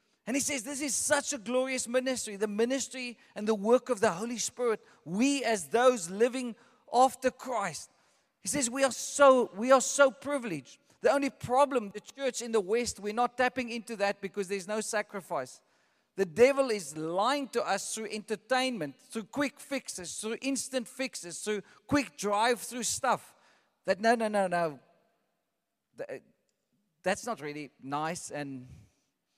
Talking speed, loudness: 160 wpm, -30 LUFS